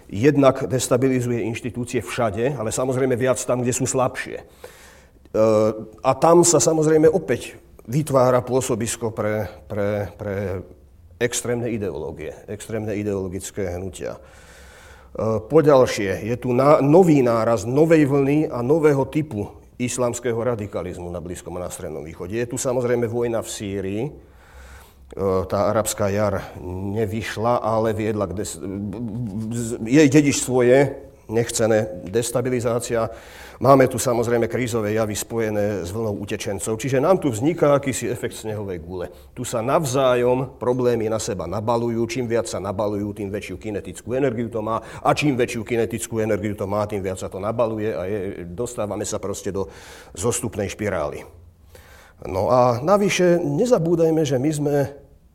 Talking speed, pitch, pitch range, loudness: 140 wpm, 115 Hz, 105-125 Hz, -21 LUFS